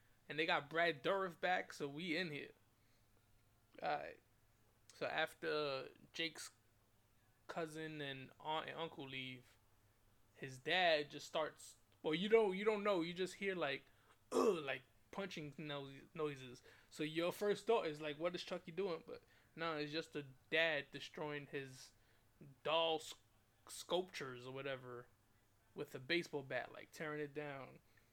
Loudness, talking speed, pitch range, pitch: -42 LUFS, 150 wpm, 120-165 Hz, 145 Hz